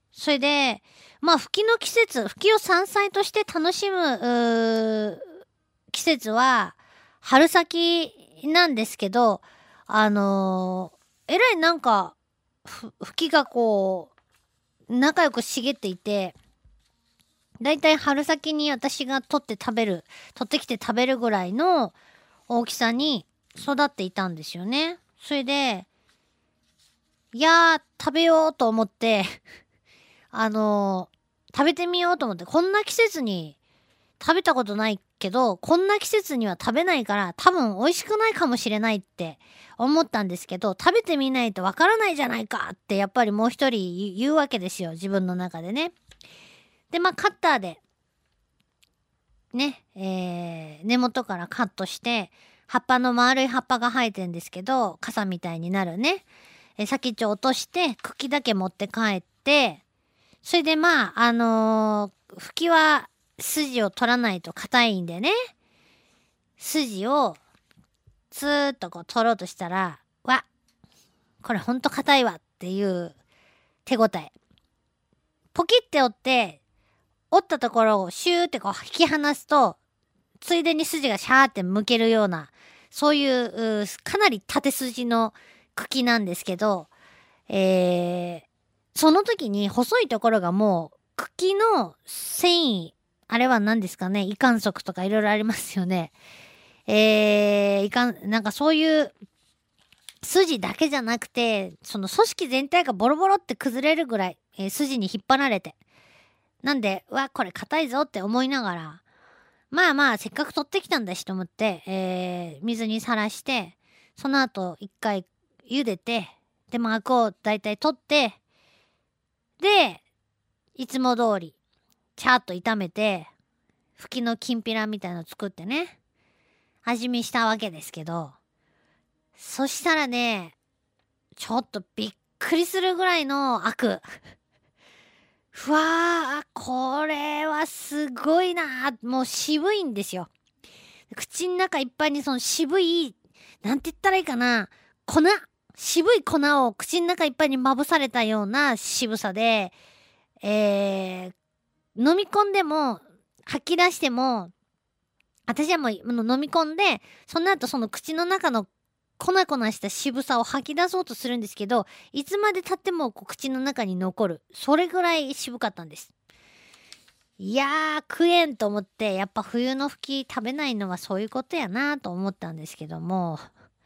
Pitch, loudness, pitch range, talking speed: 240 Hz, -24 LUFS, 200-300 Hz, 270 characters per minute